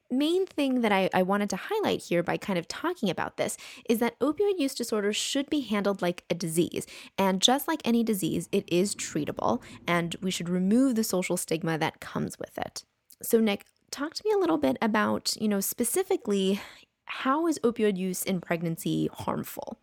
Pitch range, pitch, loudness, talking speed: 185-270 Hz, 215 Hz, -28 LUFS, 195 wpm